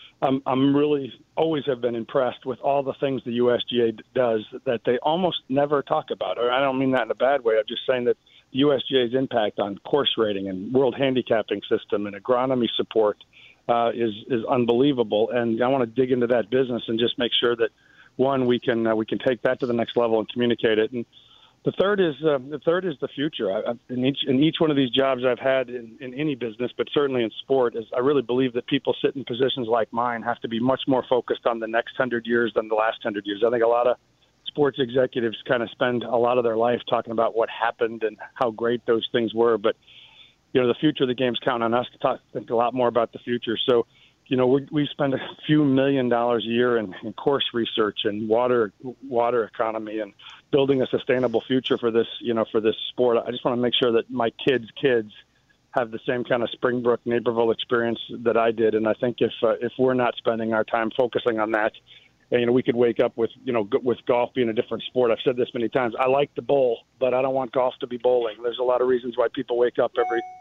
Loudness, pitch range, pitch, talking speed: -23 LUFS, 115-135 Hz, 120 Hz, 245 wpm